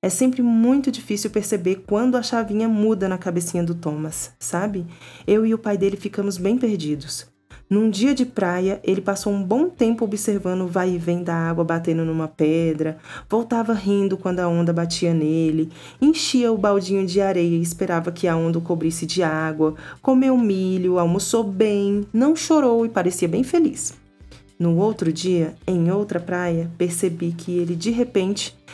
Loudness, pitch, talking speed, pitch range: -21 LUFS, 190 Hz, 175 wpm, 170-220 Hz